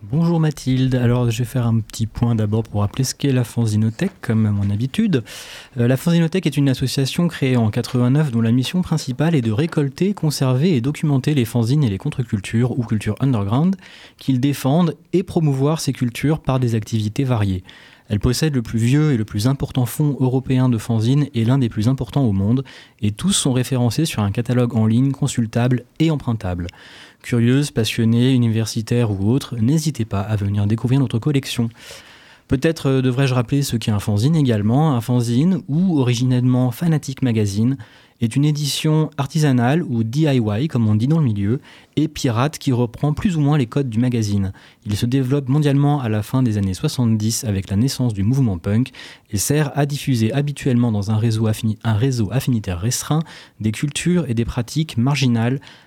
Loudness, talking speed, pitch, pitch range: -19 LUFS, 185 wpm, 125 Hz, 115-145 Hz